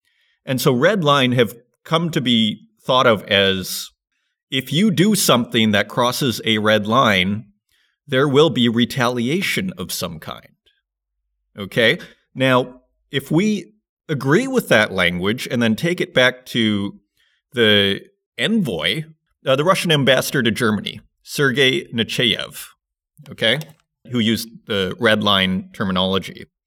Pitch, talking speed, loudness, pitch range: 125 Hz, 130 wpm, -18 LUFS, 105-160 Hz